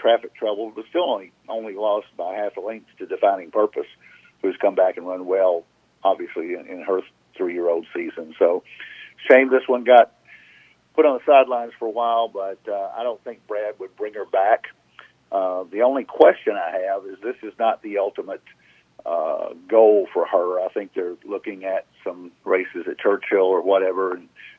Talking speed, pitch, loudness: 185 wpm, 210 Hz, -21 LUFS